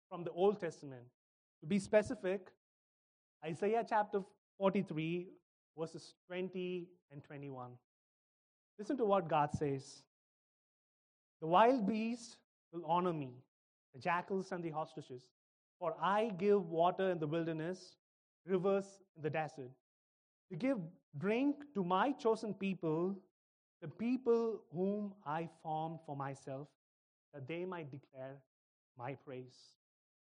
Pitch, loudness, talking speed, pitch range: 170 Hz, -38 LUFS, 120 wpm, 145-195 Hz